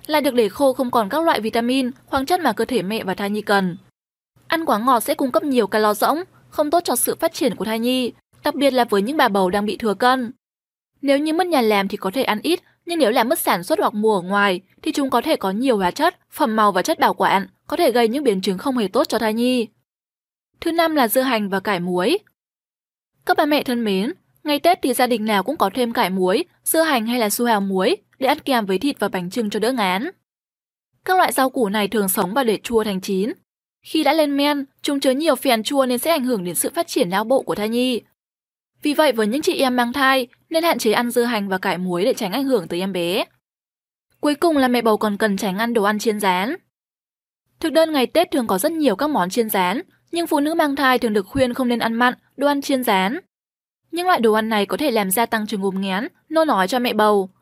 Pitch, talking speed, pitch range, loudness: 245 Hz, 265 wpm, 210-290 Hz, -19 LUFS